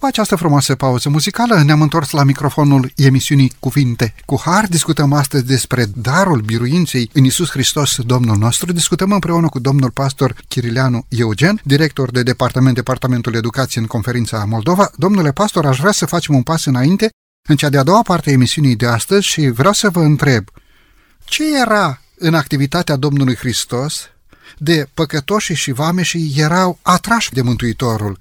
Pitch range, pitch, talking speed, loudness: 125-170 Hz, 145 Hz, 160 wpm, -14 LUFS